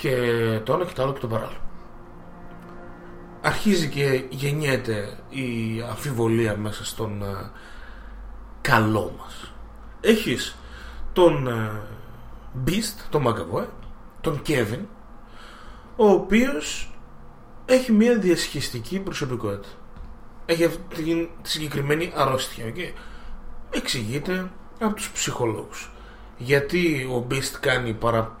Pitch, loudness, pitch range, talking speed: 130 Hz, -24 LUFS, 115-165 Hz, 105 wpm